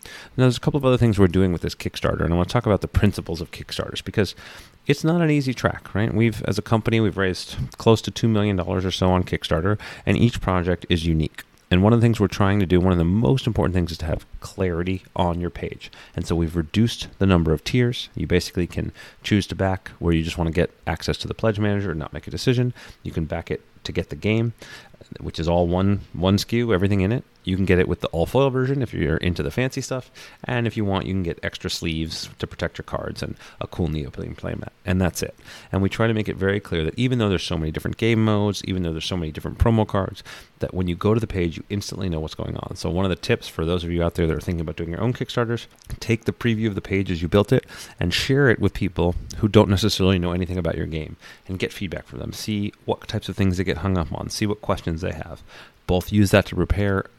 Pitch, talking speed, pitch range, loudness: 95 Hz, 275 wpm, 85-110 Hz, -23 LUFS